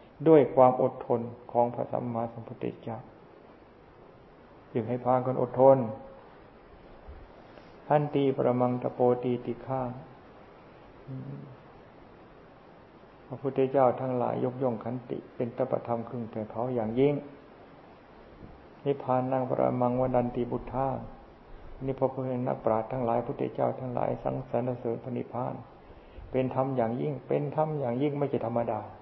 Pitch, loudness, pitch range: 125 Hz, -29 LUFS, 115-130 Hz